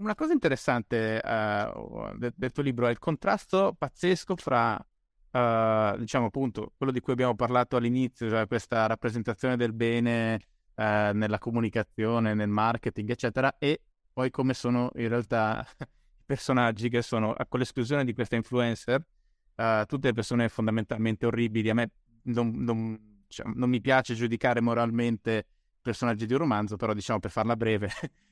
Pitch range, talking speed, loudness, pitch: 110-125 Hz, 155 wpm, -28 LUFS, 120 Hz